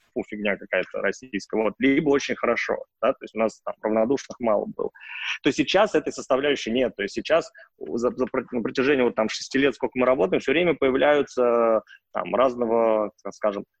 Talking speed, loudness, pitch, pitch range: 185 wpm, -24 LUFS, 130 Hz, 115-140 Hz